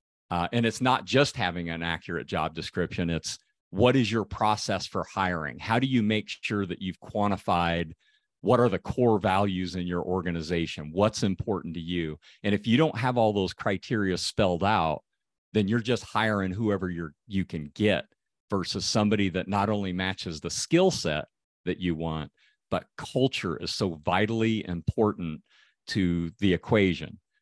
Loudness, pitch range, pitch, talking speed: -28 LUFS, 85-110 Hz, 100 Hz, 170 wpm